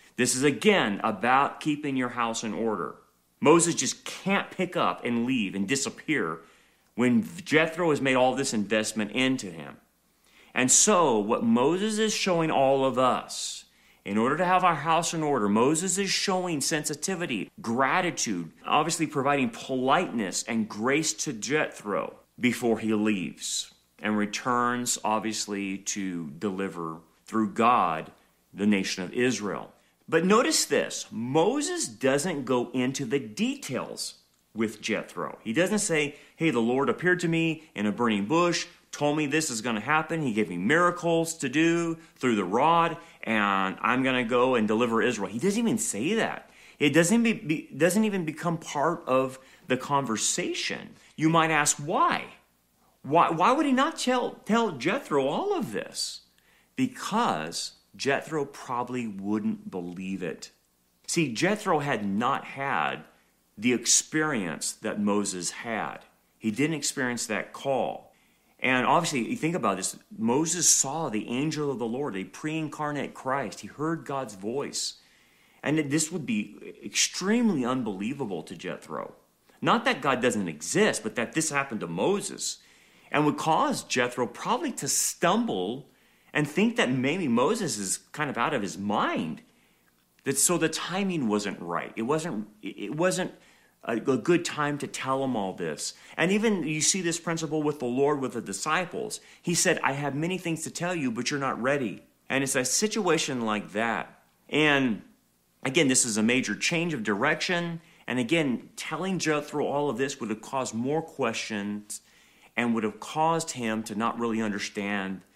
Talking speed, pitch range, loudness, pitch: 160 wpm, 115-170 Hz, -27 LUFS, 140 Hz